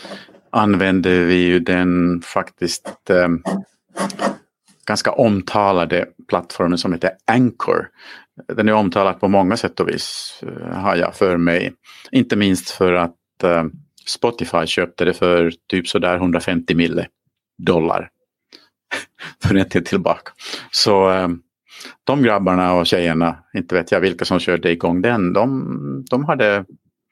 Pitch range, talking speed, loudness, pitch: 85-95 Hz, 130 wpm, -18 LUFS, 90 Hz